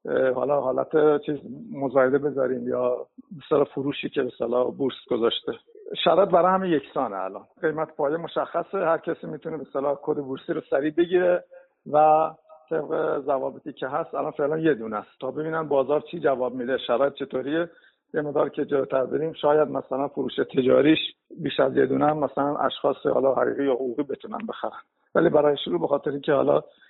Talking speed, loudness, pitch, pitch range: 165 wpm, -24 LUFS, 150 Hz, 135-160 Hz